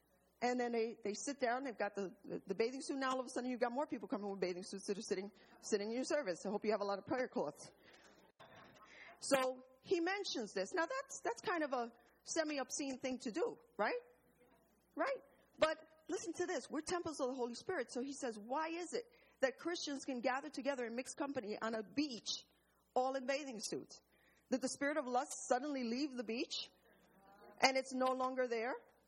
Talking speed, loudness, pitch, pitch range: 215 wpm, -41 LUFS, 260 Hz, 235-295 Hz